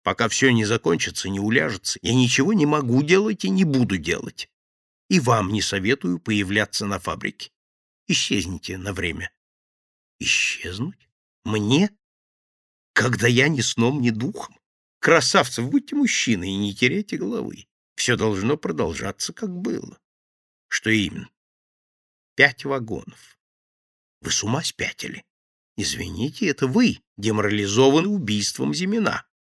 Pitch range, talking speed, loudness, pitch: 100-140 Hz, 120 wpm, -22 LUFS, 115 Hz